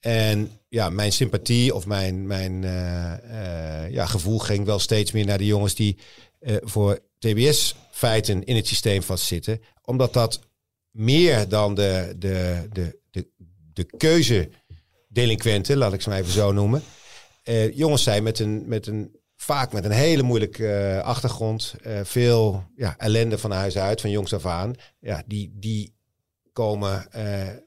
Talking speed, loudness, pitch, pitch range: 145 wpm, -23 LUFS, 105 Hz, 100-115 Hz